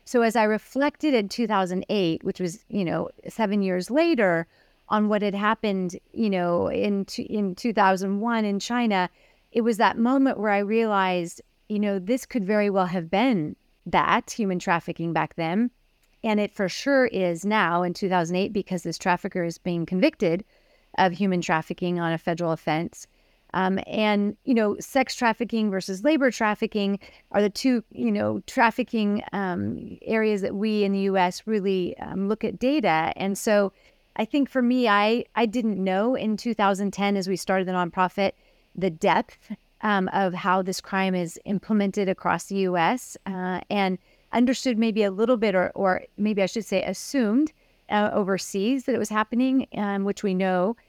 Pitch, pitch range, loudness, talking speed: 200 Hz, 185-225 Hz, -24 LUFS, 170 wpm